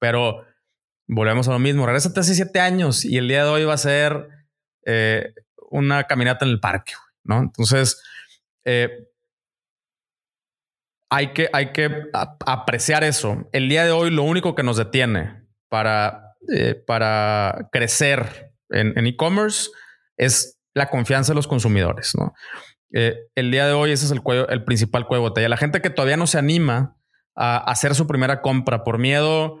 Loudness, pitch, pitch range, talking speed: -20 LUFS, 135 Hz, 120-150 Hz, 170 wpm